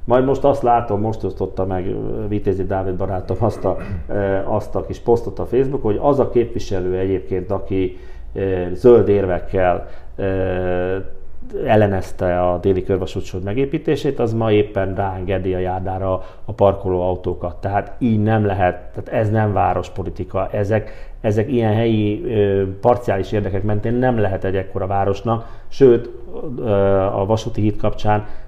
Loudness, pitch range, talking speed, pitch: -19 LUFS, 95-110 Hz, 135 wpm, 100 Hz